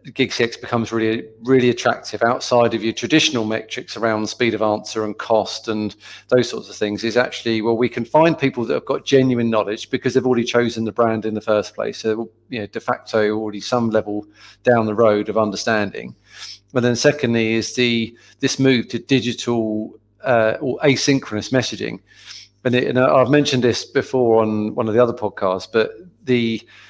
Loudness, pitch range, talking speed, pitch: -19 LUFS, 110-125 Hz, 190 wpm, 115 Hz